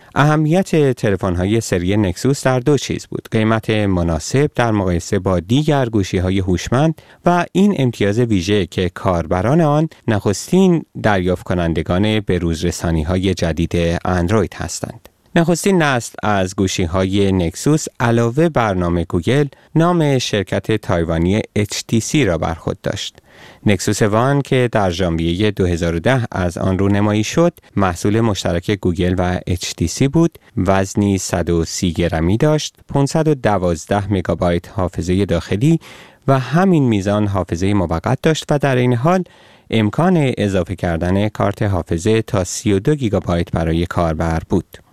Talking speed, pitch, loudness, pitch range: 130 wpm, 105 Hz, -17 LUFS, 90-130 Hz